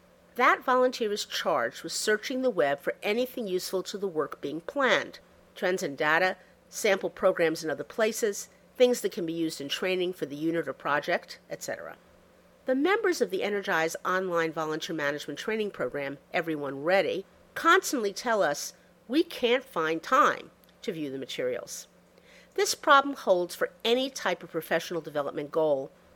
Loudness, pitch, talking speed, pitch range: -28 LUFS, 185 Hz, 160 wpm, 165-245 Hz